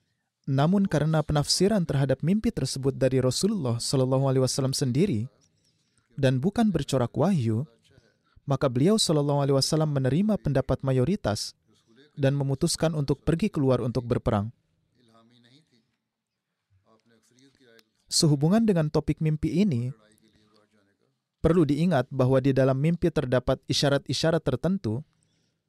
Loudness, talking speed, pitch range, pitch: -25 LUFS, 105 wpm, 125-155 Hz, 135 Hz